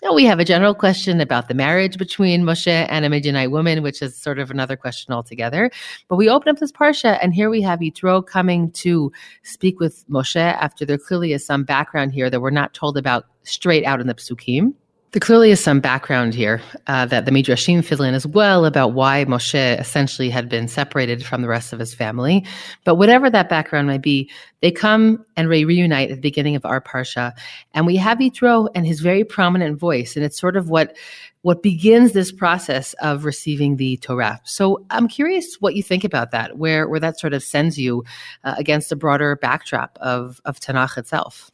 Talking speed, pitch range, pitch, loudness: 210 wpm, 130-185 Hz, 150 Hz, -18 LUFS